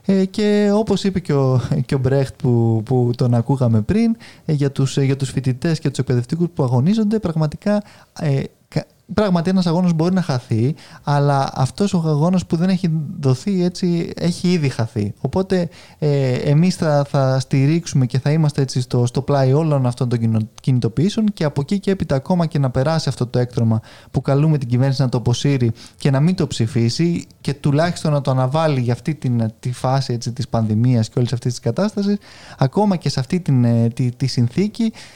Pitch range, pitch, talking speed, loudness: 125-170 Hz, 140 Hz, 180 wpm, -19 LUFS